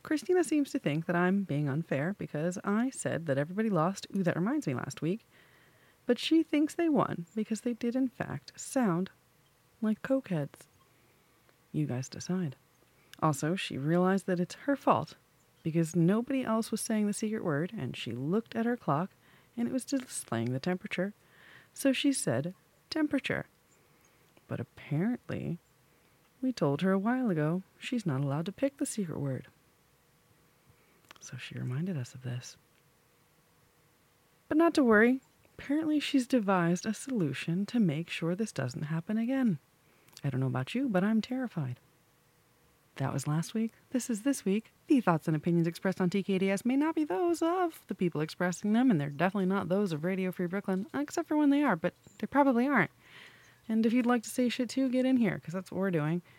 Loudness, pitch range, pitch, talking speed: -31 LUFS, 160-250 Hz, 195 Hz, 180 wpm